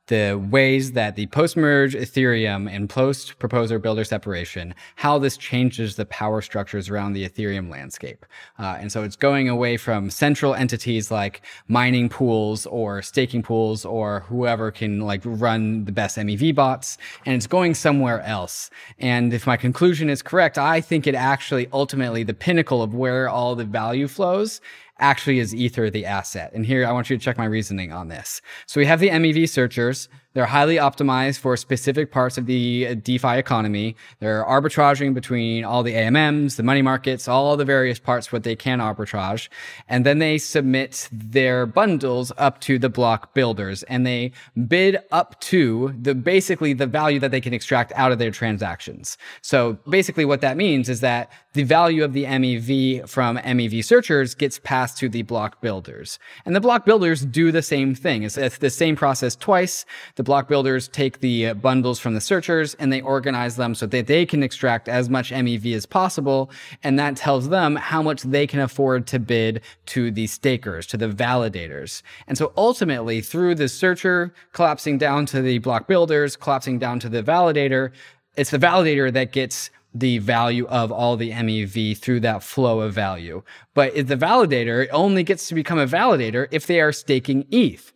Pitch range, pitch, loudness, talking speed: 115-140 Hz, 130 Hz, -20 LUFS, 180 wpm